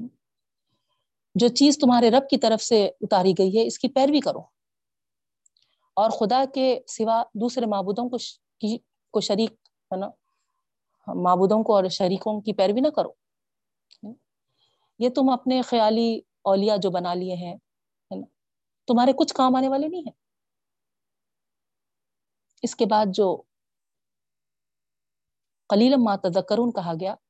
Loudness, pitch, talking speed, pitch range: -22 LUFS, 225 Hz, 130 wpm, 205-260 Hz